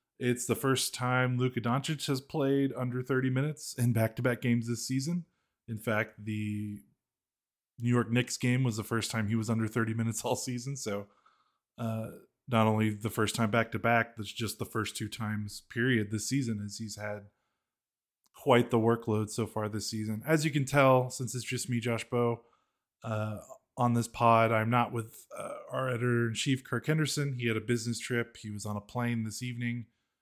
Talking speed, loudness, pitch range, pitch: 190 wpm, -31 LUFS, 110-125 Hz, 120 Hz